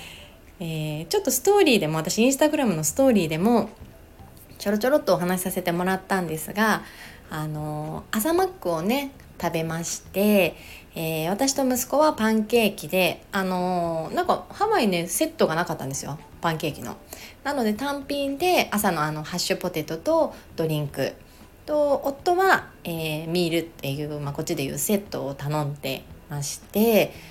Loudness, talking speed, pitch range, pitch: -24 LUFS, 345 characters per minute, 160-255 Hz, 185 Hz